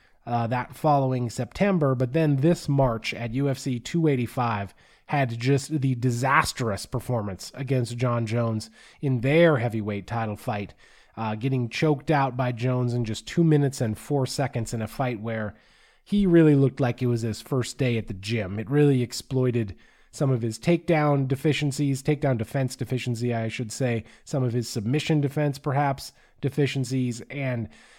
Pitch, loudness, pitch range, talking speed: 130 Hz, -25 LUFS, 115-140 Hz, 160 wpm